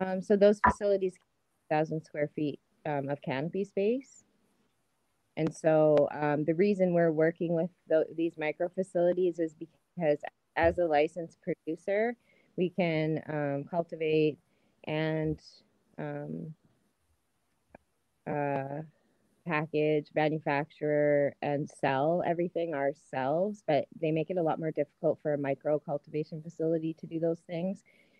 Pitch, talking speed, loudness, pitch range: 160 Hz, 130 wpm, -31 LUFS, 150-175 Hz